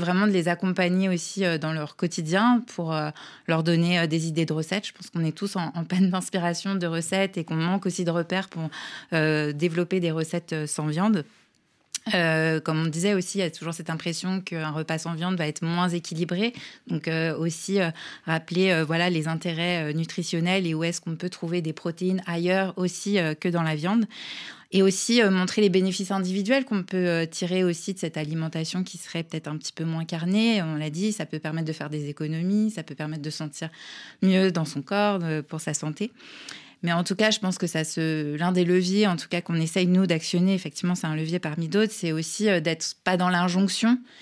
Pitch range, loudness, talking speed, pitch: 160-190 Hz, -26 LUFS, 215 wpm, 175 Hz